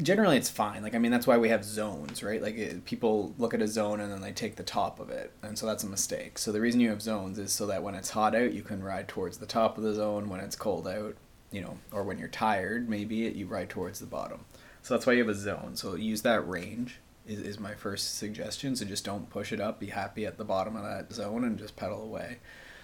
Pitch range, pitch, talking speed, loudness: 100-110 Hz, 105 Hz, 275 wpm, -32 LUFS